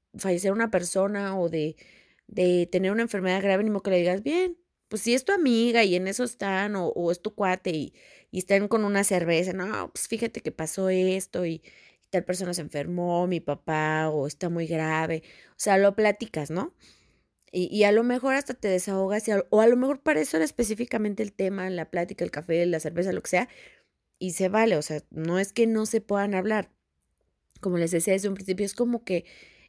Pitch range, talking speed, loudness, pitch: 175-215 Hz, 220 wpm, -25 LUFS, 190 Hz